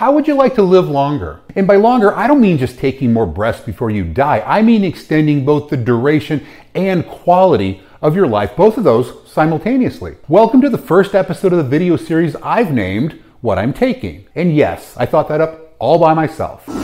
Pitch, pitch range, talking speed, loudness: 160 Hz, 135-195 Hz, 205 wpm, -14 LUFS